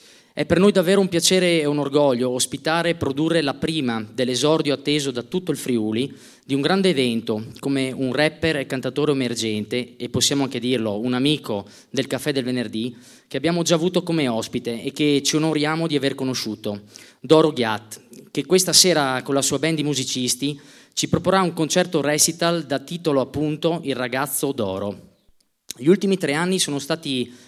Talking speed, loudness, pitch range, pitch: 175 wpm, -21 LUFS, 125-160 Hz, 140 Hz